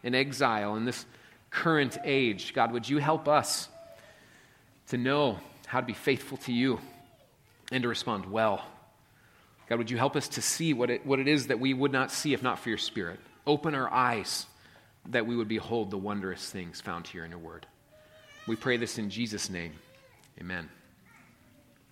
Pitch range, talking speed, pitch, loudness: 105-135 Hz, 185 wpm, 120 Hz, -30 LUFS